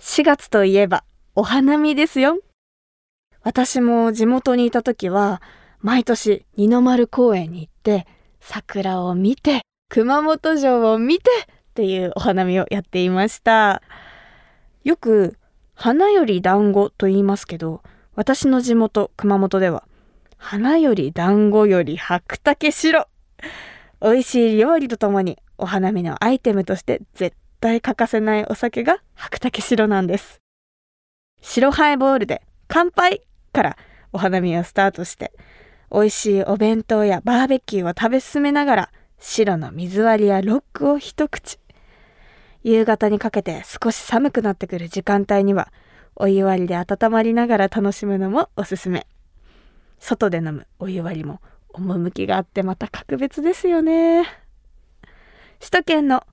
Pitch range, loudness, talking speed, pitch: 195-255 Hz, -18 LUFS, 265 characters per minute, 215 Hz